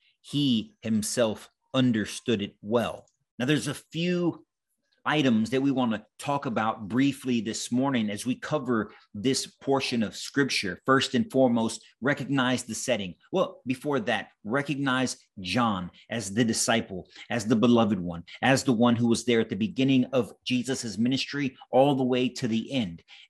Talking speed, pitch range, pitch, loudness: 160 wpm, 115-135 Hz, 125 Hz, -27 LUFS